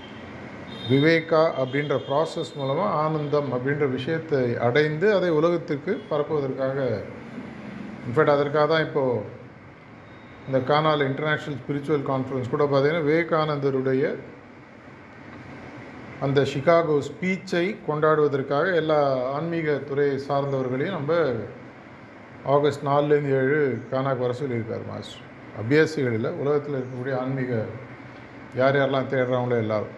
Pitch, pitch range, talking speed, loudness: 140 Hz, 130-150 Hz, 95 wpm, -24 LUFS